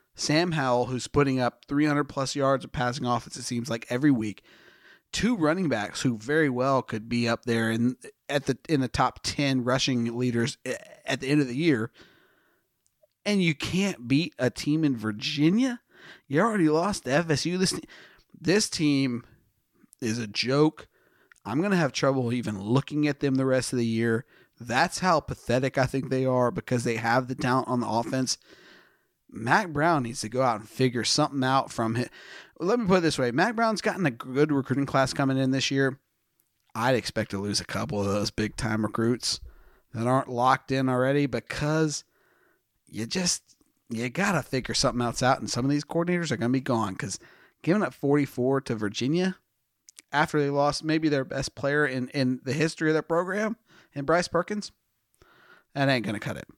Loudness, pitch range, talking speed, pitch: -26 LUFS, 120-150 Hz, 190 wpm, 135 Hz